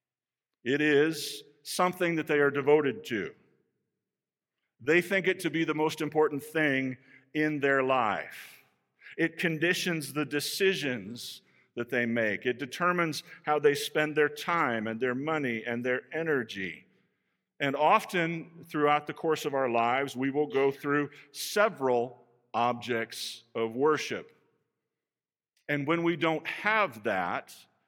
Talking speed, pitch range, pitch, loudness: 135 wpm, 130-160 Hz, 145 Hz, -29 LUFS